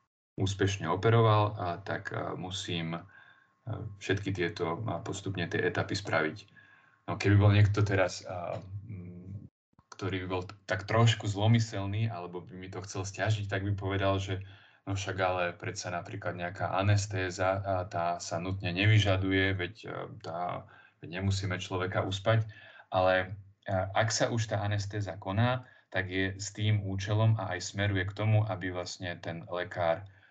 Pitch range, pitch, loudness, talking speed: 95-105 Hz, 95 Hz, -31 LUFS, 145 wpm